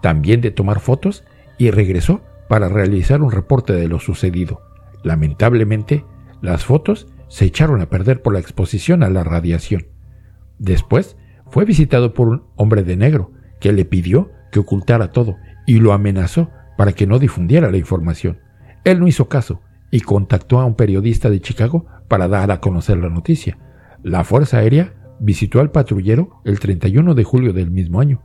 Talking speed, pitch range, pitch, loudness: 170 wpm, 95-125 Hz, 105 Hz, -15 LUFS